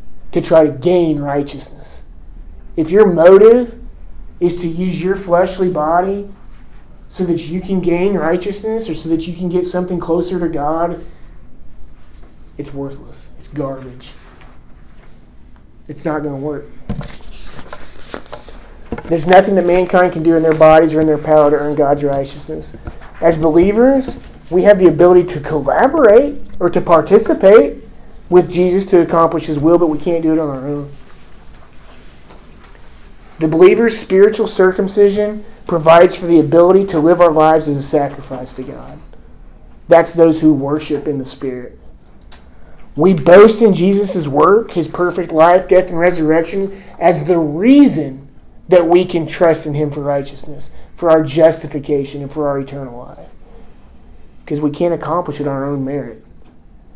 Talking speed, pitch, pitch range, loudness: 150 wpm, 160 Hz, 140-180 Hz, -12 LUFS